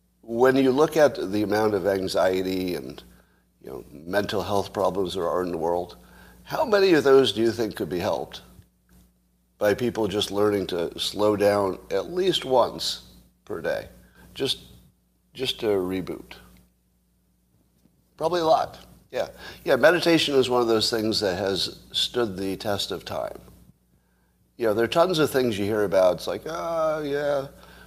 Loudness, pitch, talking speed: -24 LUFS, 100 Hz, 165 wpm